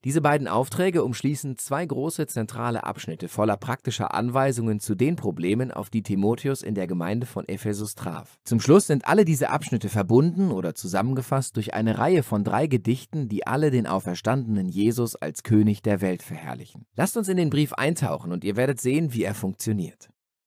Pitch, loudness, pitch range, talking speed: 120 Hz, -25 LUFS, 105-140 Hz, 180 wpm